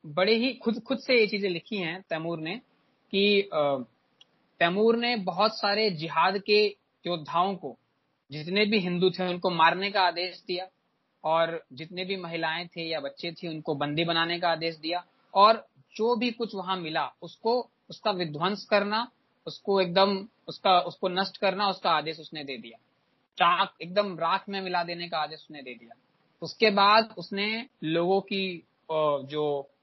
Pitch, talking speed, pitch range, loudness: 185 Hz, 165 wpm, 165-205 Hz, -27 LUFS